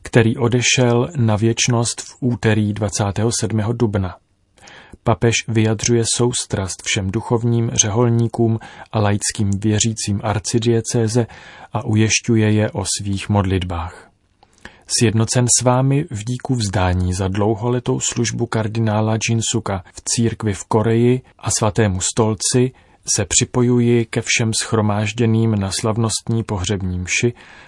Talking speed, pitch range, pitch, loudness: 115 wpm, 105-120 Hz, 115 Hz, -18 LUFS